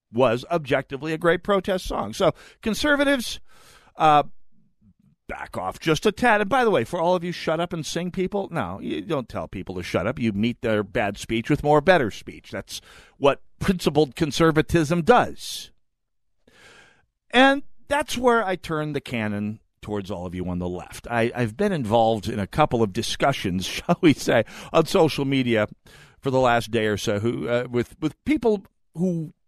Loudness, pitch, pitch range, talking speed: -23 LUFS, 150 Hz, 115-185 Hz, 185 wpm